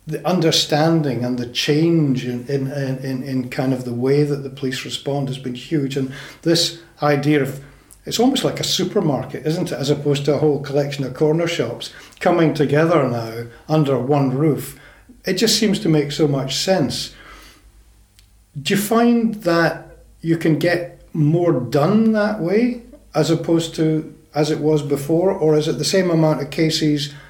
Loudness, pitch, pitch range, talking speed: -19 LUFS, 150 Hz, 135-165 Hz, 175 wpm